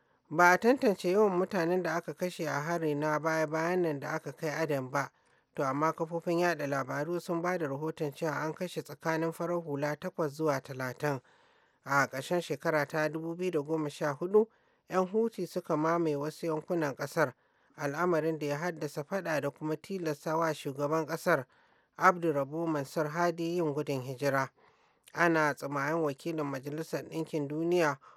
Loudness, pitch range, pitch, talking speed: -32 LUFS, 145-170 Hz, 160 Hz, 145 wpm